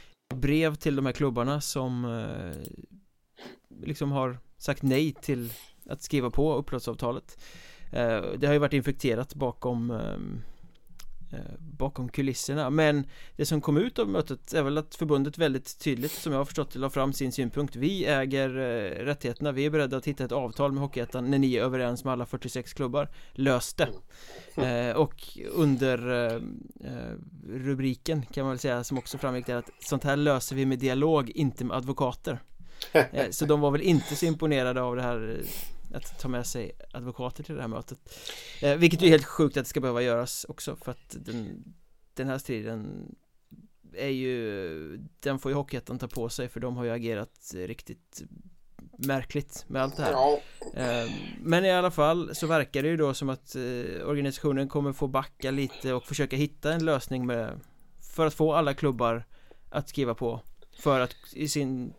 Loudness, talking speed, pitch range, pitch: -29 LUFS, 180 wpm, 125-150 Hz, 135 Hz